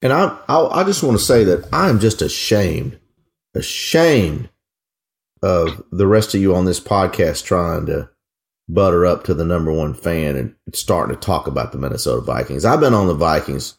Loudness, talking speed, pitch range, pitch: -17 LUFS, 190 wpm, 85-110 Hz, 90 Hz